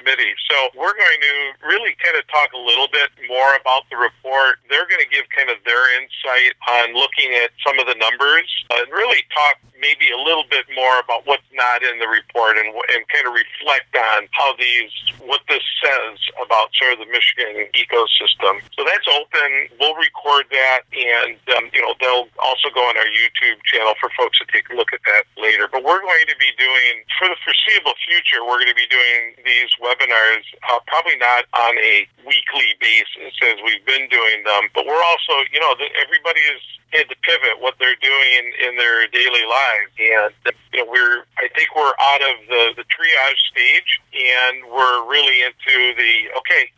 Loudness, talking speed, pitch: -15 LUFS, 195 wpm, 140 Hz